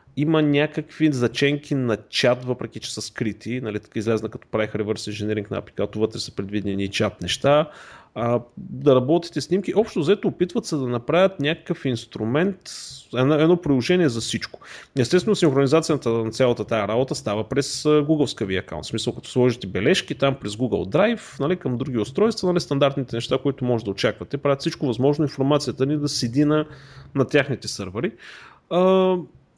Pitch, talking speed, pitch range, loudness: 135 Hz, 165 wpm, 115-155 Hz, -22 LUFS